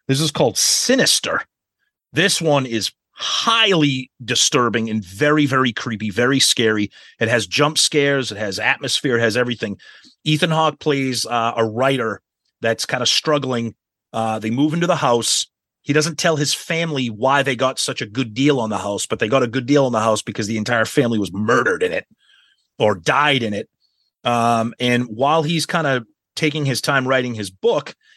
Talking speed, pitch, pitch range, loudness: 190 wpm, 130 Hz, 115-150 Hz, -18 LUFS